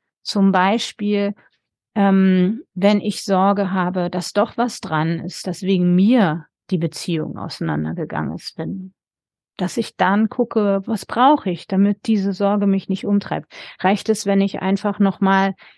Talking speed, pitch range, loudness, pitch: 150 wpm, 185-205 Hz, -19 LUFS, 195 Hz